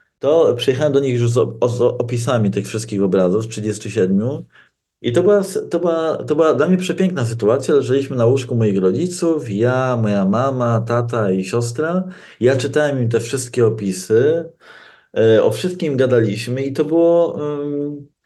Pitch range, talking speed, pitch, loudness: 115-165 Hz, 165 wpm, 135 Hz, -17 LUFS